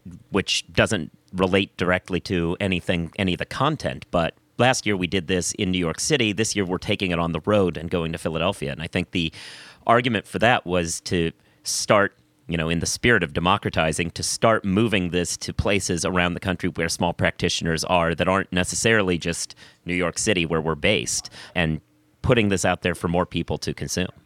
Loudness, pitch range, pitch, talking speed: -23 LUFS, 85-100 Hz, 90 Hz, 205 wpm